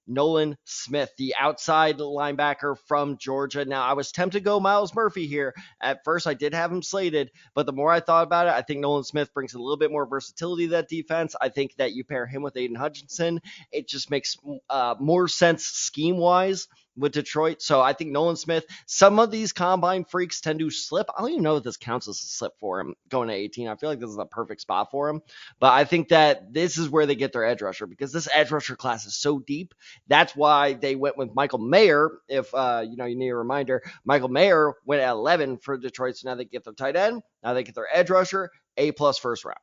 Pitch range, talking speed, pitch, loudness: 135-170 Hz, 240 wpm, 145 Hz, -24 LUFS